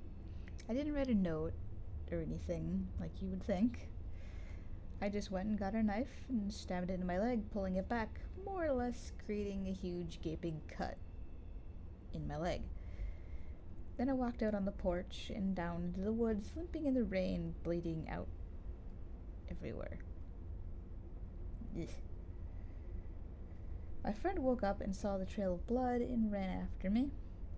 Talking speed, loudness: 155 wpm, -41 LUFS